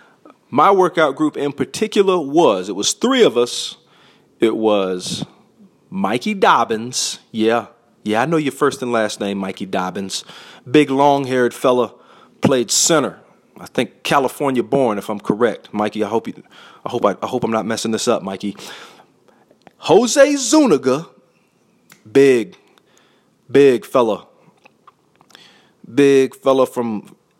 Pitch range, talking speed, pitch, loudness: 110-150 Hz, 135 wpm, 130 Hz, -17 LUFS